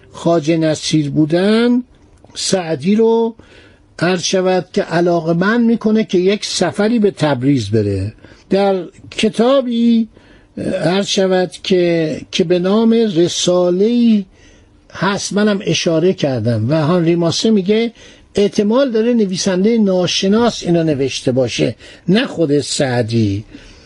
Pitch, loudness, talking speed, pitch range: 185 Hz, -15 LUFS, 110 wpm, 160-210 Hz